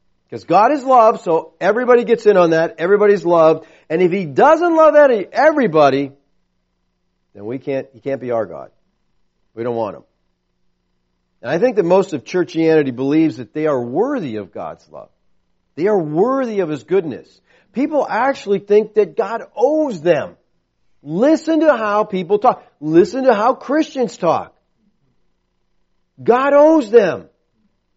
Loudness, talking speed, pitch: -15 LUFS, 150 wpm, 180 Hz